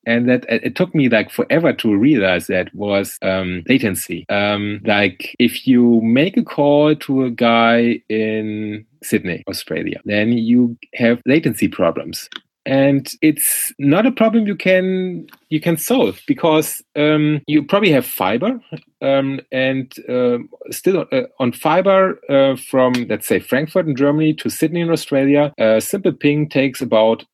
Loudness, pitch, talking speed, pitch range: -16 LUFS, 140 Hz, 155 wpm, 115-170 Hz